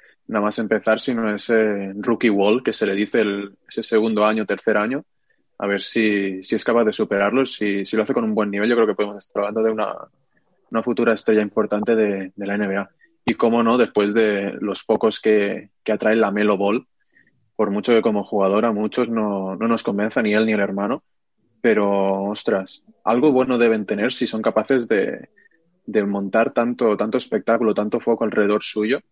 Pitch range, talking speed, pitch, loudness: 100-115 Hz, 200 wpm, 105 Hz, -20 LUFS